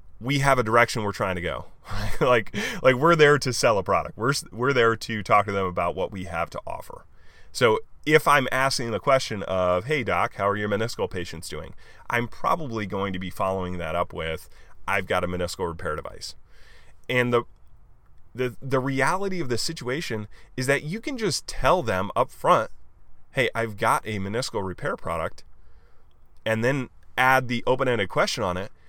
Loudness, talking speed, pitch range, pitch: -24 LUFS, 190 wpm, 95-135 Hz, 115 Hz